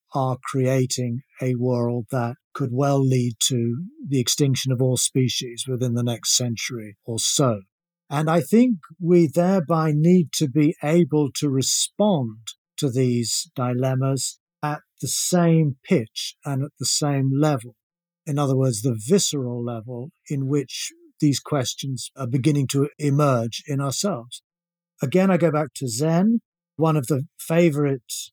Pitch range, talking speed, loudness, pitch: 125-165 Hz, 145 wpm, -22 LUFS, 140 Hz